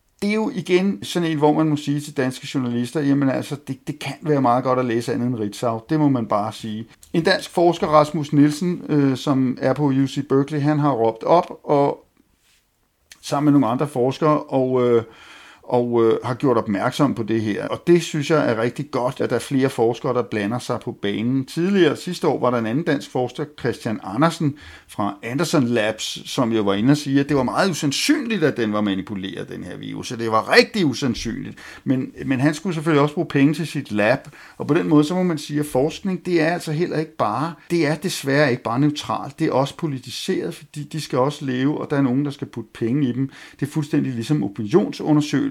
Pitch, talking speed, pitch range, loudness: 140 Hz, 230 wpm, 125-155 Hz, -21 LUFS